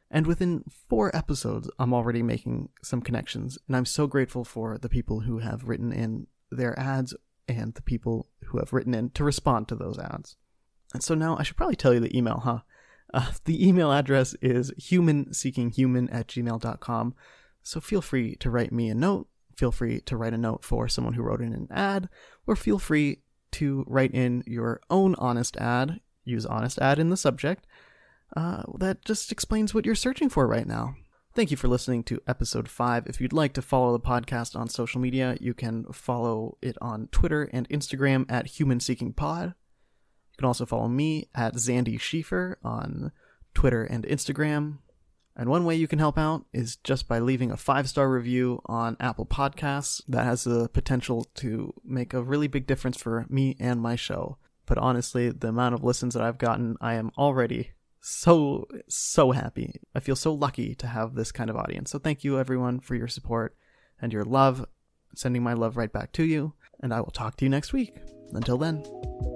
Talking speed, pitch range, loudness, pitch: 195 wpm, 120-145 Hz, -27 LUFS, 125 Hz